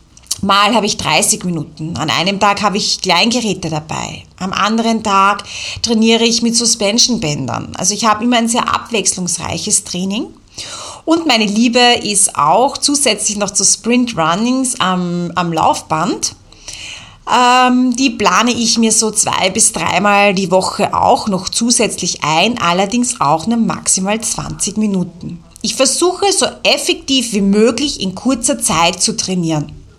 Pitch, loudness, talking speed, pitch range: 210 Hz, -13 LUFS, 145 wpm, 185-235 Hz